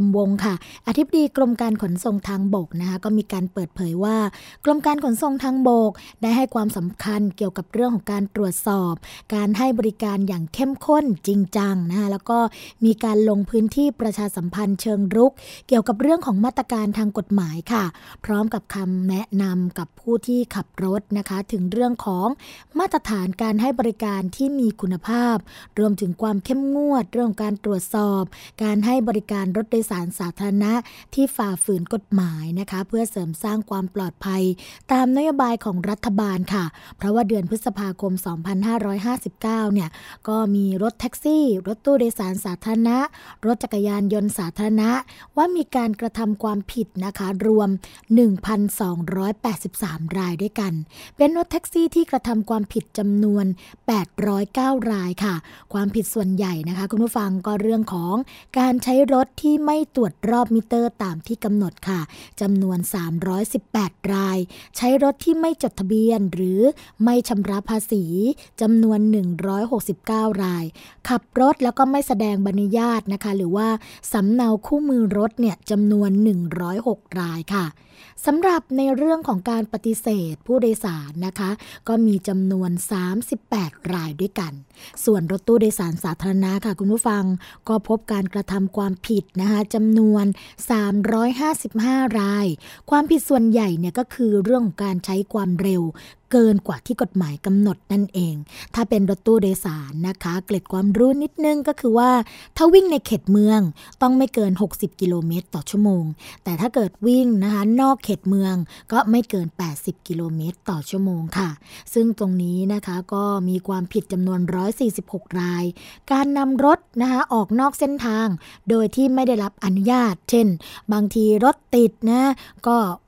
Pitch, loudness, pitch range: 210 Hz, -21 LUFS, 195-235 Hz